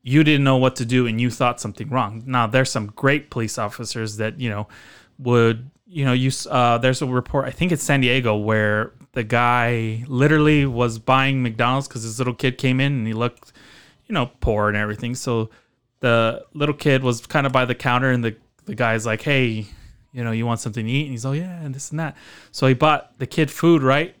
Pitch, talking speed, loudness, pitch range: 125 Hz, 230 wpm, -20 LUFS, 115-135 Hz